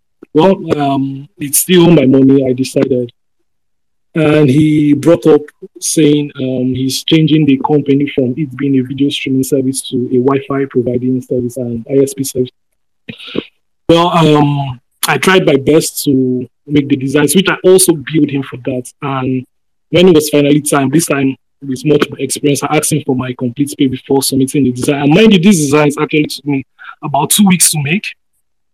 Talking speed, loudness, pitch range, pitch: 180 wpm, -11 LUFS, 130-150 Hz, 140 Hz